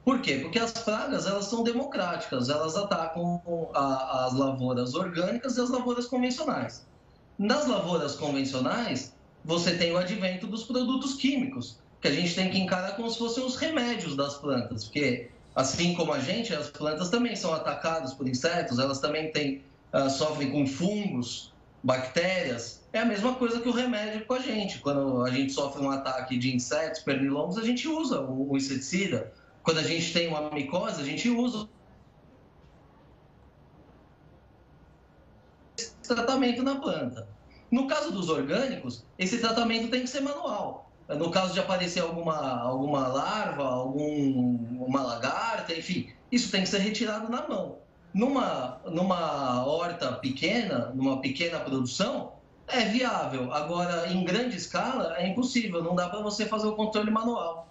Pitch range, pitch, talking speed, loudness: 140-230 Hz, 175 Hz, 155 wpm, -29 LUFS